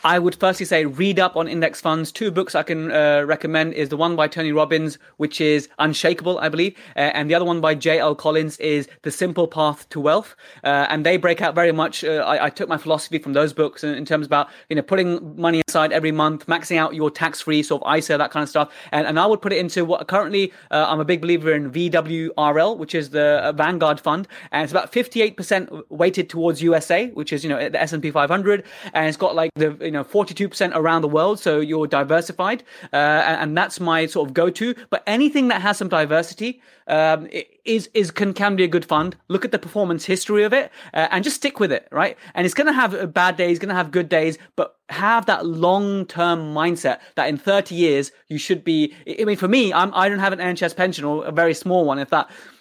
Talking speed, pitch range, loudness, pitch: 240 wpm, 155-185 Hz, -20 LUFS, 165 Hz